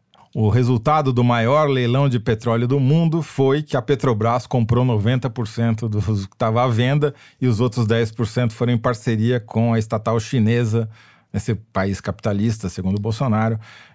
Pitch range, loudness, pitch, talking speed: 110-130 Hz, -20 LUFS, 120 Hz, 155 wpm